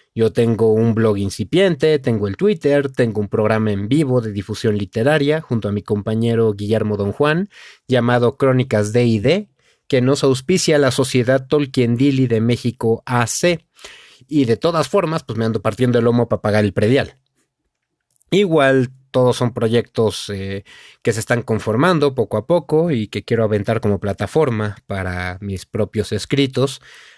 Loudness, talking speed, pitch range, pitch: -18 LUFS, 165 wpm, 110-140 Hz, 120 Hz